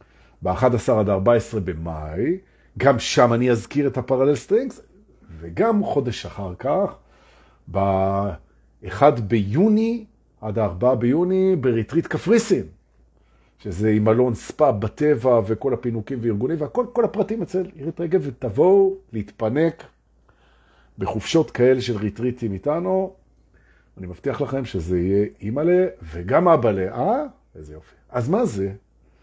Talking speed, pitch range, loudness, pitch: 115 wpm, 100-155 Hz, -21 LUFS, 120 Hz